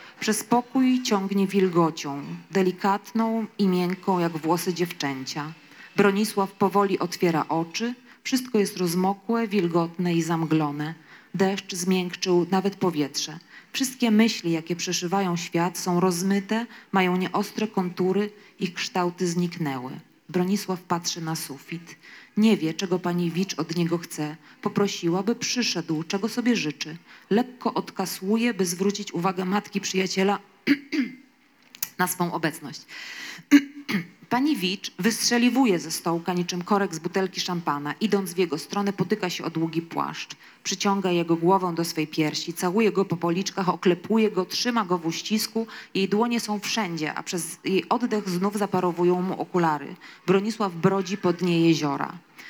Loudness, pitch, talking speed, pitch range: -25 LUFS, 185 Hz, 135 wpm, 170-205 Hz